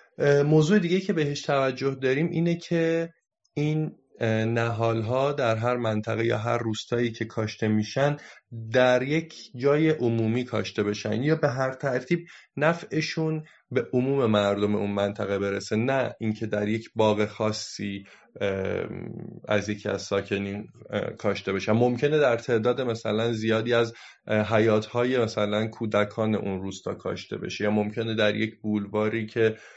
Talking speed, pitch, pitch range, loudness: 135 wpm, 115 Hz, 105-135 Hz, -26 LUFS